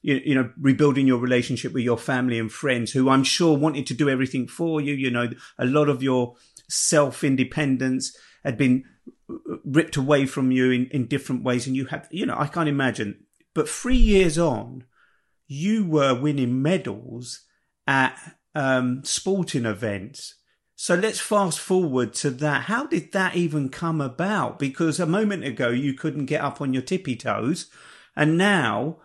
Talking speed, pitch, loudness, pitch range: 170 wpm, 140 Hz, -23 LUFS, 130-160 Hz